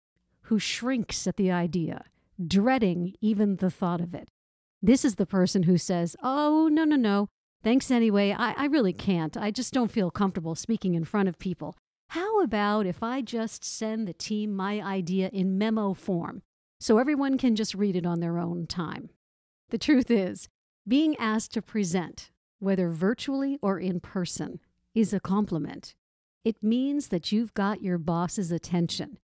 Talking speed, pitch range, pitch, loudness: 170 wpm, 180-230 Hz, 200 Hz, -27 LUFS